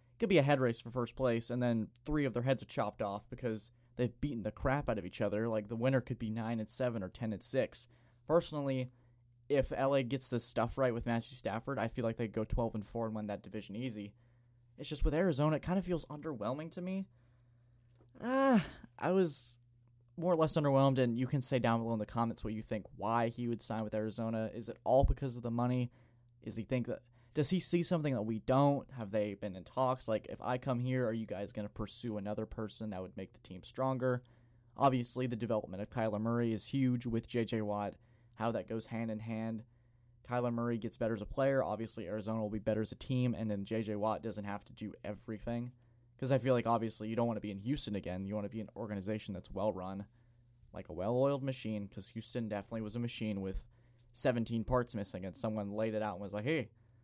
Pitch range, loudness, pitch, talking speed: 110-125 Hz, -34 LUFS, 120 Hz, 240 wpm